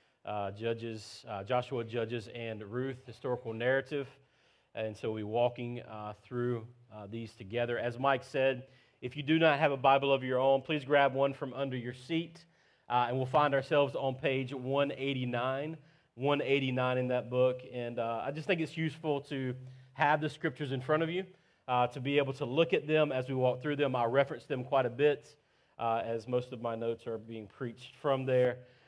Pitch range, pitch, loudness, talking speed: 120-145 Hz, 130 Hz, -33 LUFS, 195 wpm